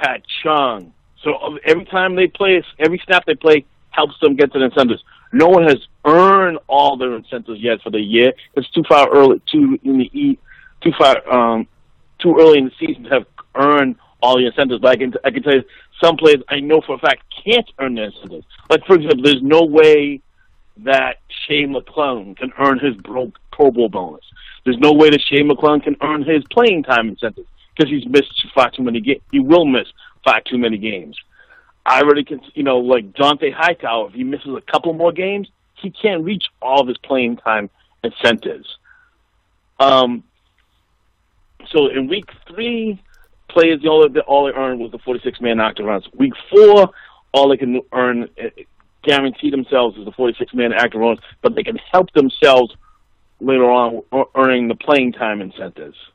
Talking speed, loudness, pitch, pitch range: 190 wpm, -15 LUFS, 140 Hz, 125-160 Hz